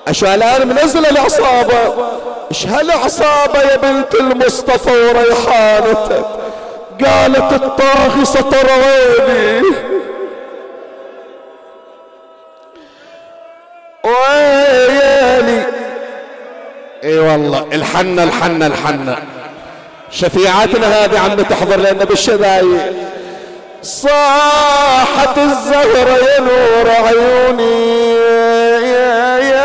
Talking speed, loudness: 60 wpm, -10 LUFS